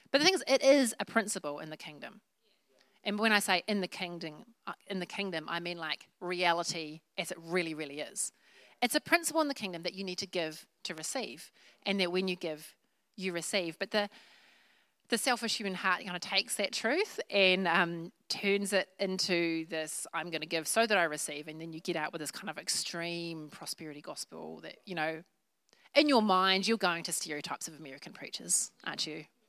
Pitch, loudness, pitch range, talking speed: 180 Hz, -32 LUFS, 165-205 Hz, 210 wpm